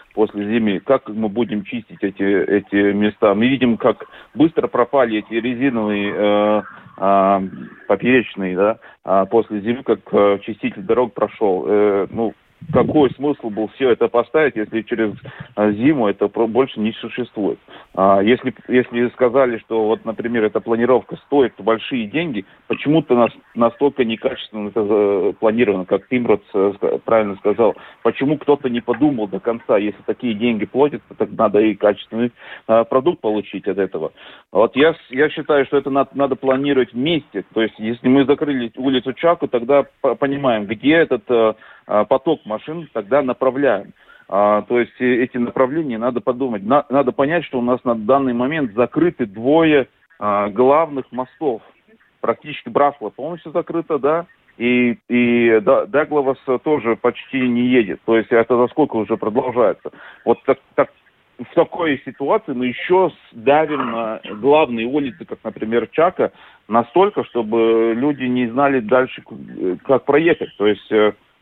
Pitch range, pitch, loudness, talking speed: 110-135 Hz, 120 Hz, -18 LUFS, 145 wpm